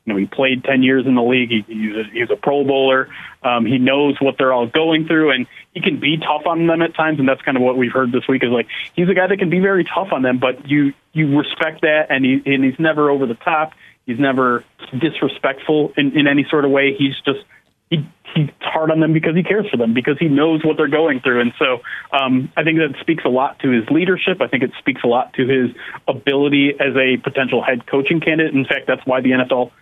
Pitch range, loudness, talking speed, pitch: 130-160 Hz, -16 LUFS, 260 wpm, 140 Hz